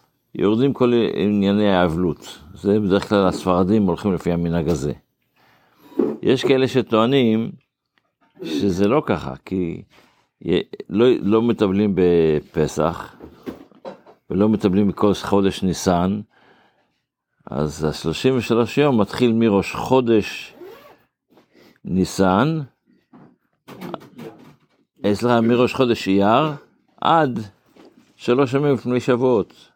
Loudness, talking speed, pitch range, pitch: -19 LUFS, 90 wpm, 90-120 Hz, 105 Hz